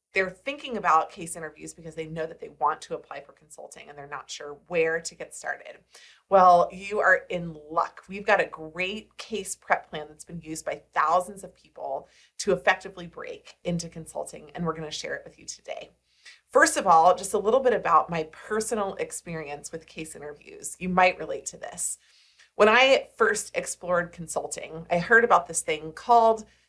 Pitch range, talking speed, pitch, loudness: 160-205 Hz, 195 wpm, 175 Hz, -25 LUFS